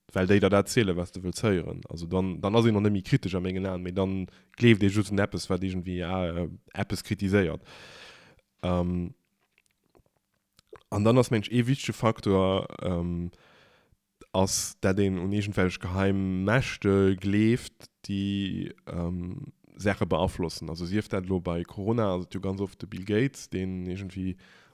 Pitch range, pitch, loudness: 90-105 Hz, 95 Hz, -28 LUFS